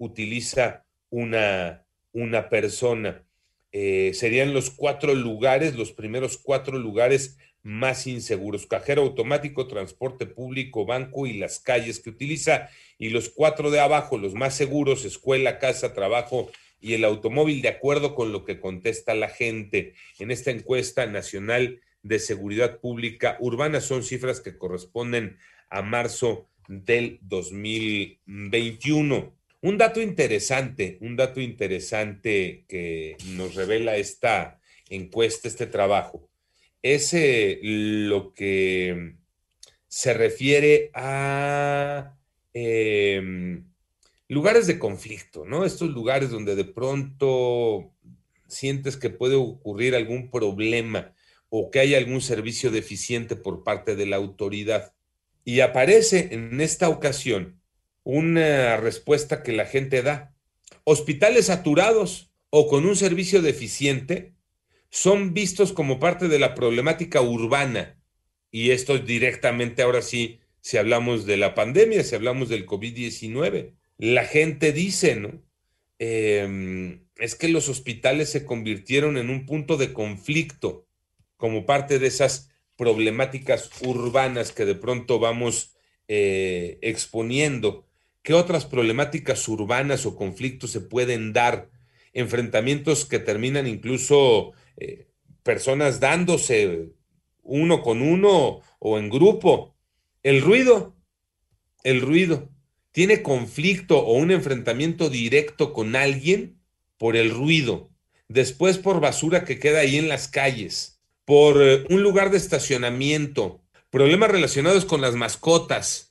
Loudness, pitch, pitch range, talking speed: -23 LUFS, 125 Hz, 110-145 Hz, 120 wpm